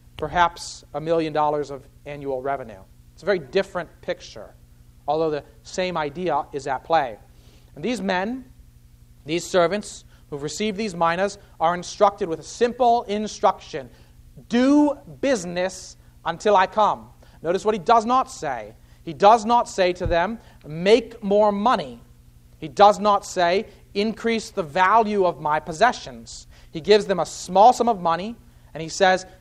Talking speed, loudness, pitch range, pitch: 155 wpm, -22 LUFS, 150-210 Hz, 180 Hz